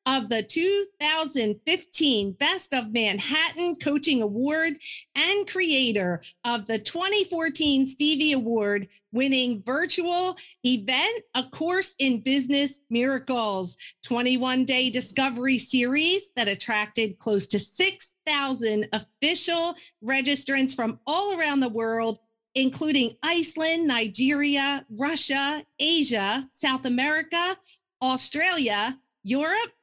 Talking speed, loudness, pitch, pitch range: 95 wpm, -24 LUFS, 270 Hz, 240-320 Hz